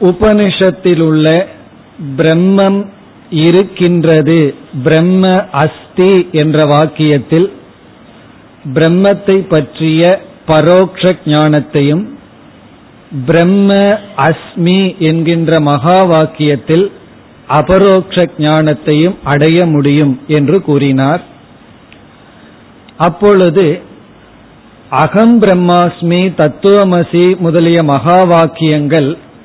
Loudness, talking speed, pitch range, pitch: -9 LUFS, 55 wpm, 155-185 Hz, 165 Hz